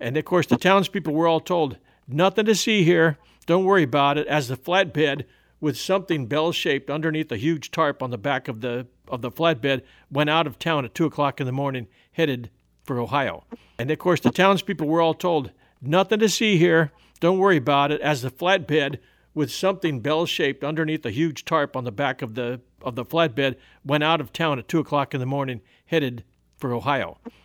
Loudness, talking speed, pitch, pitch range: -23 LUFS, 205 wpm, 150 Hz, 135-165 Hz